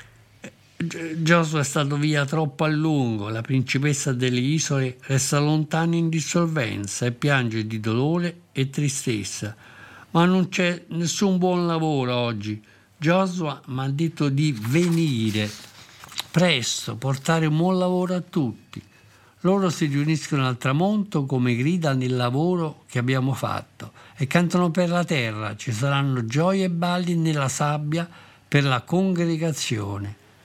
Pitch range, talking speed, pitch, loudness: 125-165 Hz, 135 wpm, 145 Hz, -23 LUFS